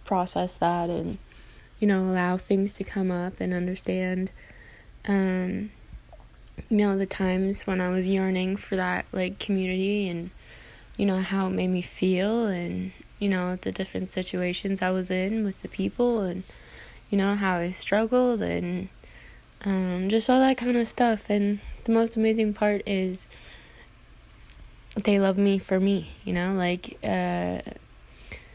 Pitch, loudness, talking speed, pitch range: 190 Hz, -26 LUFS, 155 wpm, 185-205 Hz